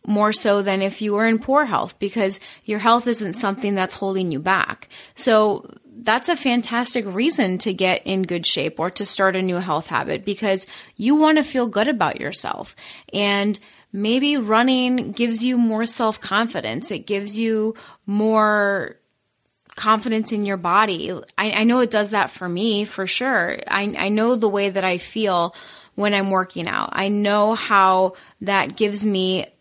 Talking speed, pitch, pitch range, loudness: 175 wpm, 210 Hz, 195-225 Hz, -20 LUFS